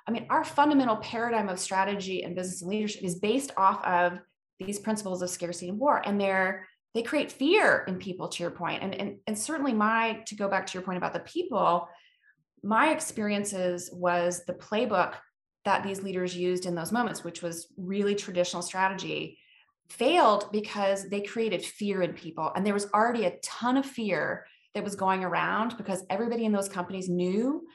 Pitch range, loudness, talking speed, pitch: 180-220 Hz, -29 LUFS, 185 wpm, 195 Hz